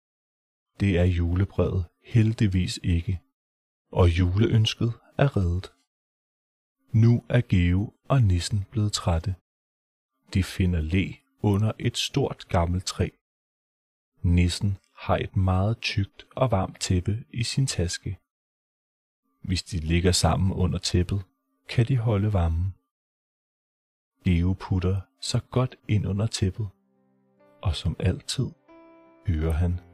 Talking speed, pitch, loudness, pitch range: 115 wpm, 95 Hz, -26 LUFS, 90-115 Hz